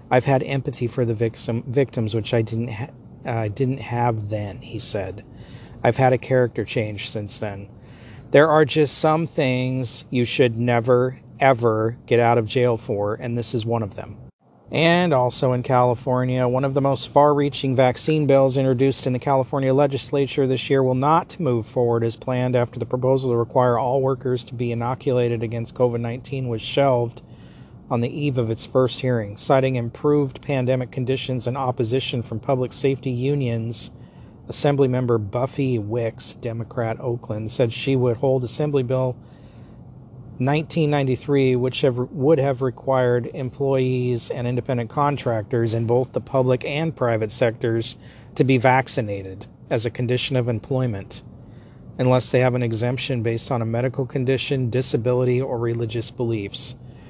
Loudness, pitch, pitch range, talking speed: -21 LUFS, 125 Hz, 115-135 Hz, 160 wpm